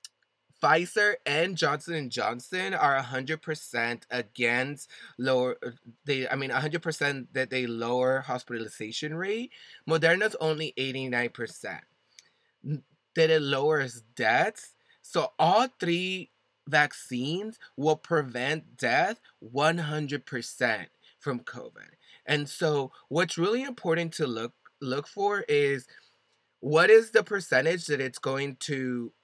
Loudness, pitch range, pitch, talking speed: -28 LUFS, 125-165 Hz, 145 Hz, 110 wpm